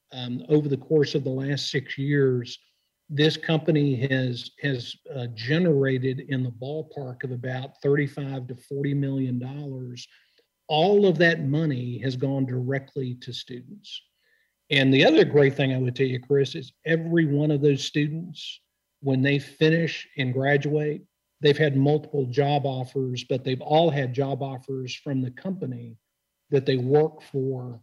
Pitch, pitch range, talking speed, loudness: 140 Hz, 130-150 Hz, 155 wpm, -24 LUFS